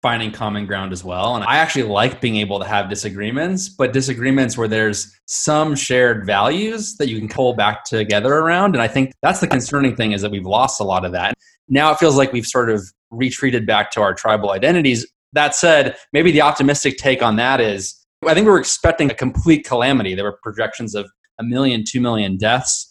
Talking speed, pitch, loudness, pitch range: 215 wpm, 125 Hz, -17 LUFS, 105-140 Hz